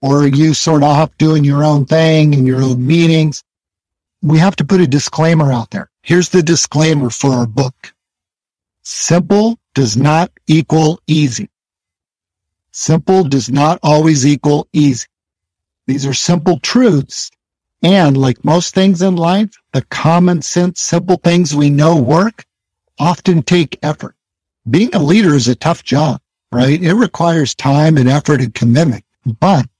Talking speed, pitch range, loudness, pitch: 155 wpm, 130-170 Hz, -12 LUFS, 150 Hz